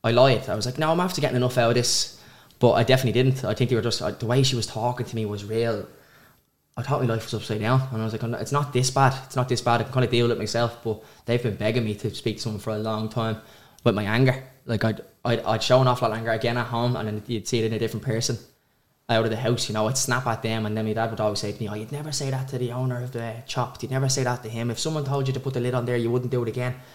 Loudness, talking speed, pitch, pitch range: -25 LUFS, 320 wpm, 120 Hz, 110-125 Hz